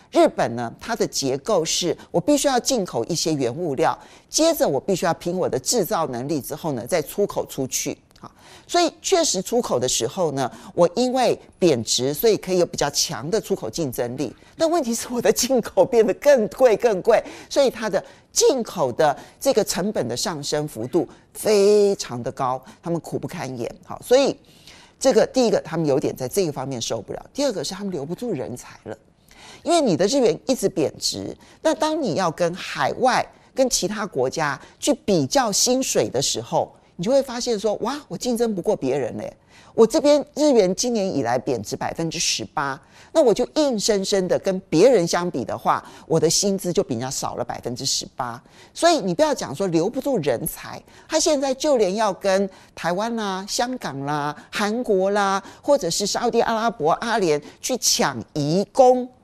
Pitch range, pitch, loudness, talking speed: 165-255 Hz, 205 Hz, -21 LUFS, 280 characters per minute